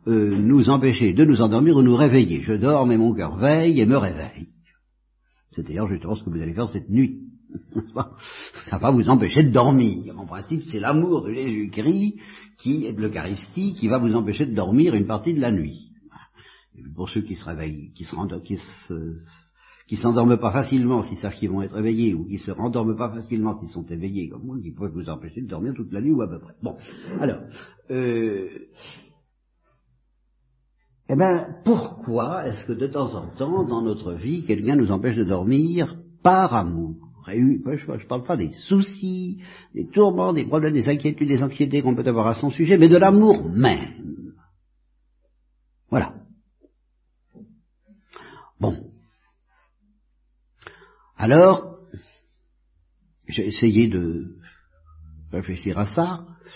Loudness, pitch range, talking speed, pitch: -21 LUFS, 90-150 Hz, 165 wpm, 115 Hz